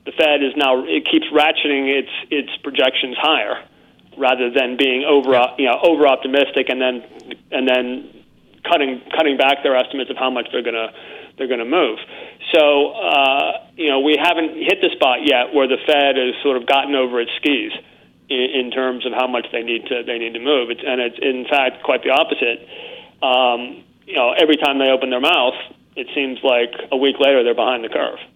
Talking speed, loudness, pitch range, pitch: 205 wpm, -17 LUFS, 125-145 Hz, 130 Hz